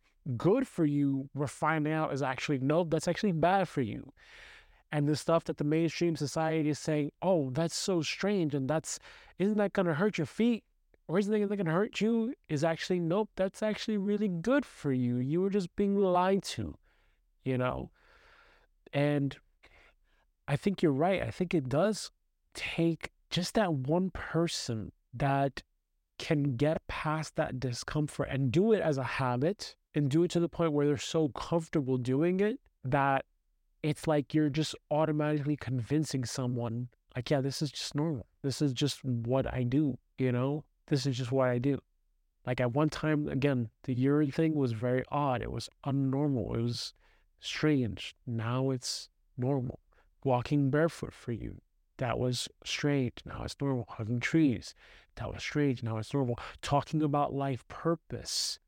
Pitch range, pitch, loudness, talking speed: 130-165 Hz, 145 Hz, -32 LUFS, 170 wpm